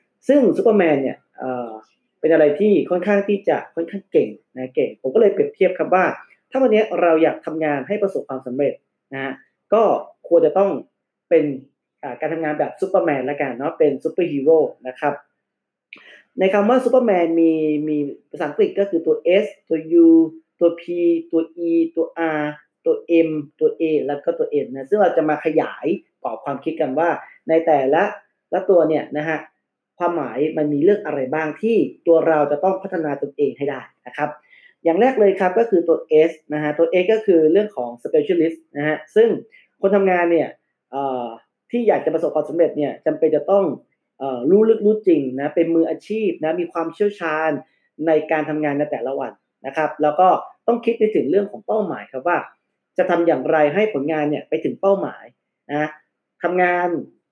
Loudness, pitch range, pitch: -19 LUFS, 150-200 Hz, 165 Hz